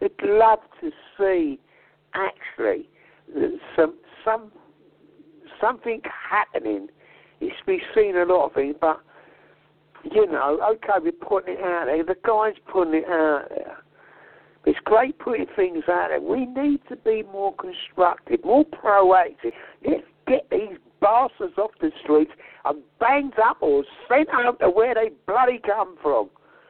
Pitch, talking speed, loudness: 260 Hz, 145 wpm, -22 LUFS